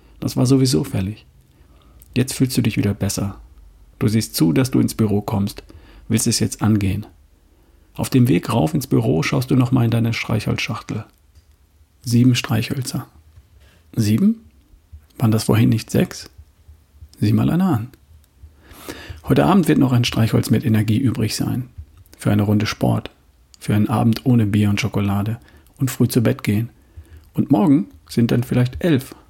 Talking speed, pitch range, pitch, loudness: 160 wpm, 80-120 Hz, 105 Hz, -19 LUFS